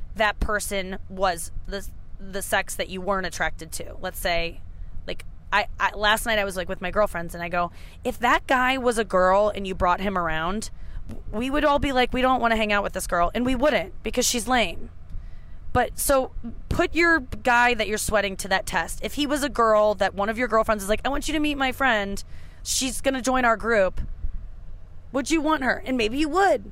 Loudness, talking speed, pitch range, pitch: -23 LUFS, 225 wpm, 180-250 Hz, 210 Hz